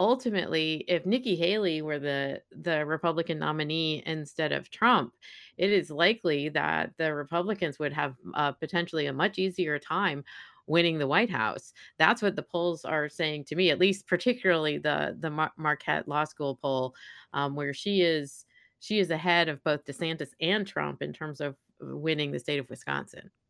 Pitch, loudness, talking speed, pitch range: 160 Hz, -29 LUFS, 175 wpm, 145-175 Hz